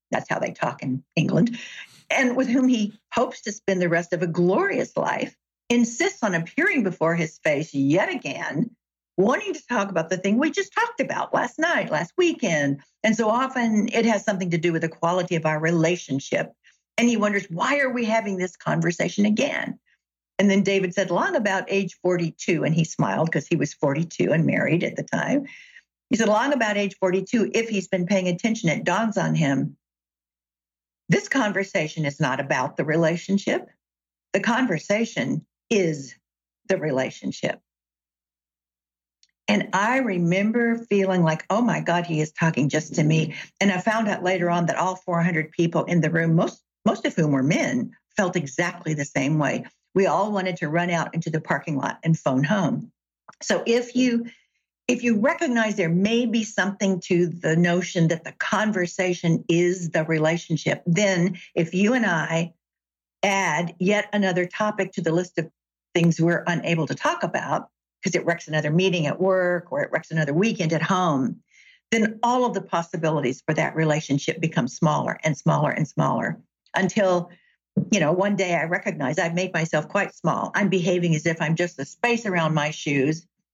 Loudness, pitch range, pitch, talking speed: -23 LUFS, 160-210 Hz, 180 Hz, 180 wpm